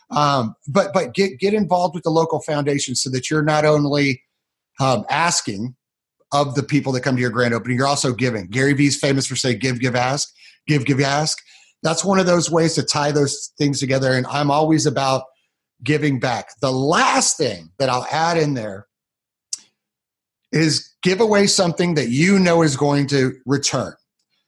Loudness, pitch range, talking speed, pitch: -19 LUFS, 130-160 Hz, 185 wpm, 145 Hz